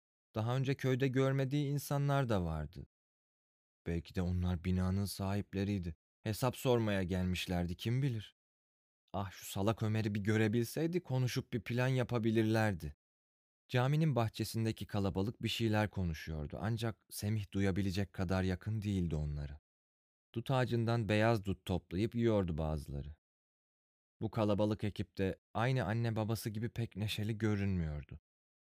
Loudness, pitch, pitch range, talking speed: -36 LUFS, 105 Hz, 90-115 Hz, 120 wpm